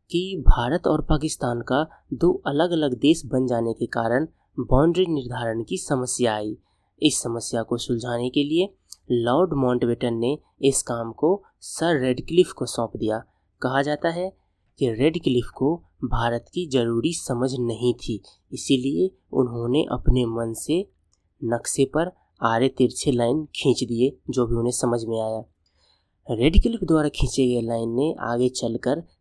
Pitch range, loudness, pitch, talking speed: 115-150 Hz, -24 LUFS, 125 Hz, 150 wpm